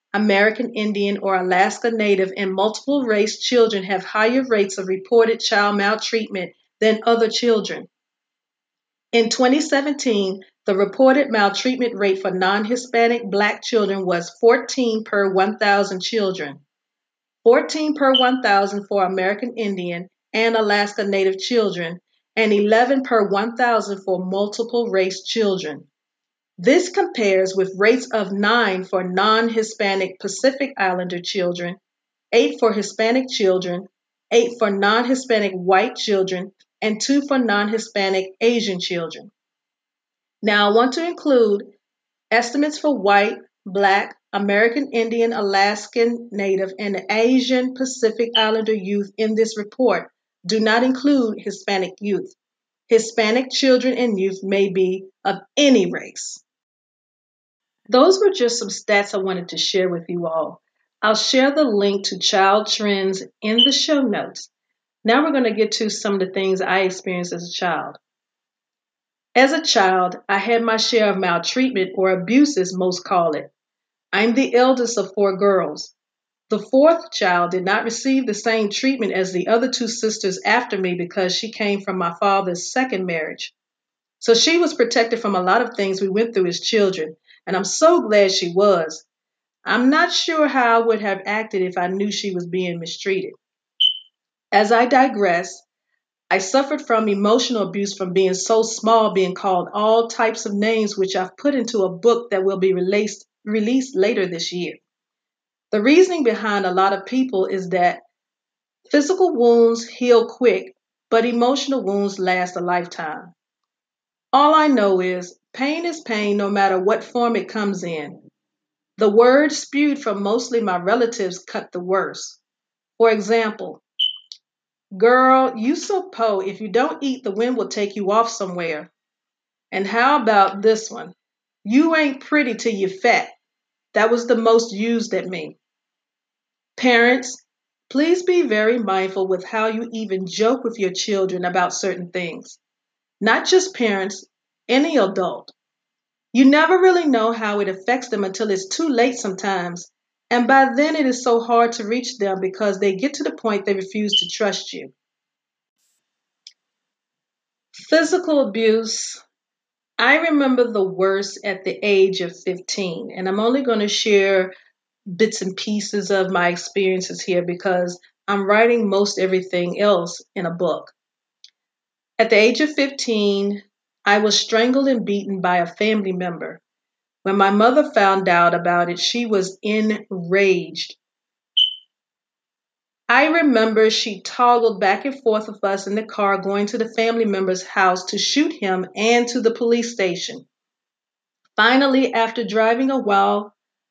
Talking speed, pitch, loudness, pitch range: 150 wpm, 215 Hz, -19 LUFS, 190-235 Hz